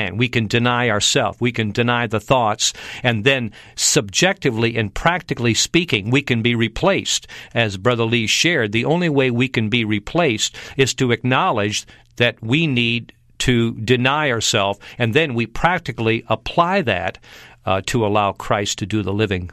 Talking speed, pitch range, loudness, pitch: 165 wpm, 110-130 Hz, -18 LUFS, 120 Hz